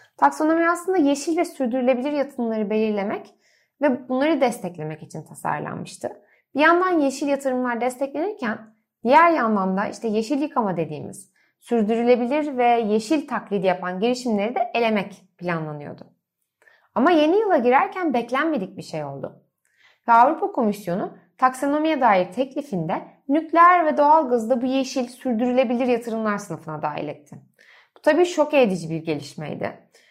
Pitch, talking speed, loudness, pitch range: 250 Hz, 125 wpm, -21 LUFS, 210-295 Hz